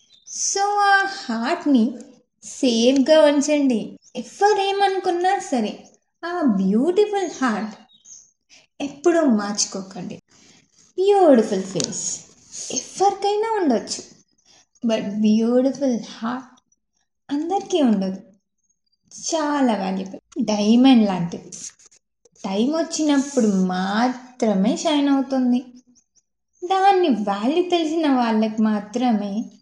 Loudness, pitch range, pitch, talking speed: -20 LUFS, 215-320 Hz, 250 Hz, 70 wpm